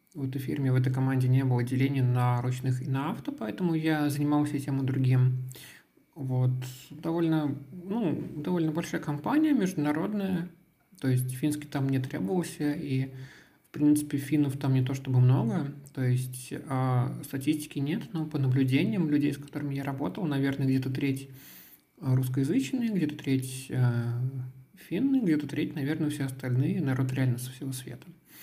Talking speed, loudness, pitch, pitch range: 150 wpm, -29 LUFS, 140 Hz, 130-155 Hz